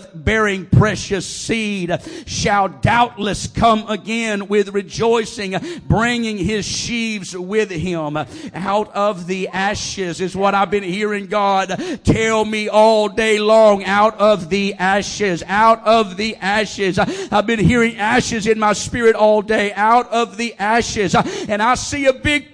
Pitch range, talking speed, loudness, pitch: 195-220 Hz, 145 wpm, -17 LUFS, 210 Hz